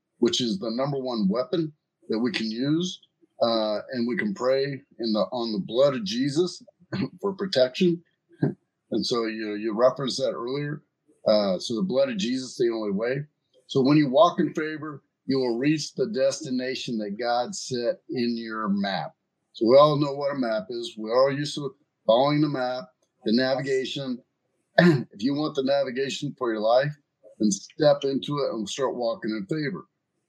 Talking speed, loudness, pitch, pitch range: 185 wpm, -25 LUFS, 140 Hz, 120-160 Hz